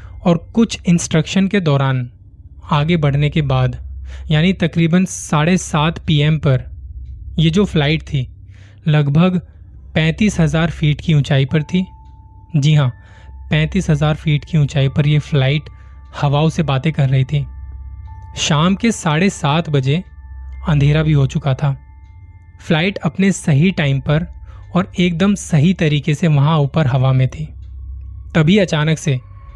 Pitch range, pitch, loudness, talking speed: 100-165 Hz, 150 Hz, -16 LUFS, 145 wpm